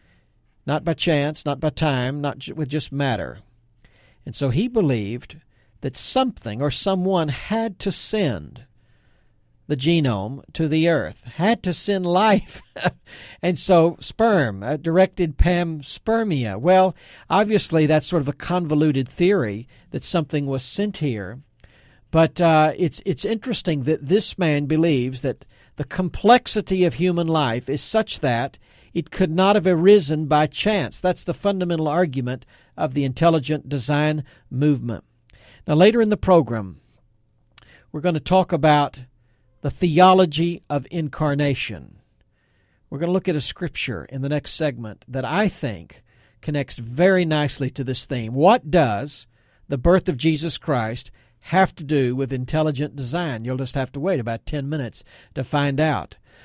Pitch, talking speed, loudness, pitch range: 150 Hz, 150 wpm, -21 LUFS, 130-175 Hz